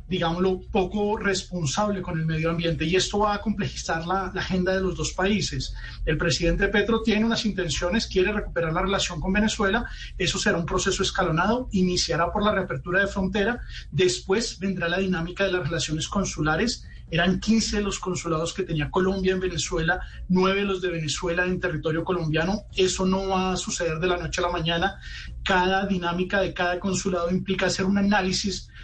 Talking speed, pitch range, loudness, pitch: 180 wpm, 170-195 Hz, -25 LUFS, 185 Hz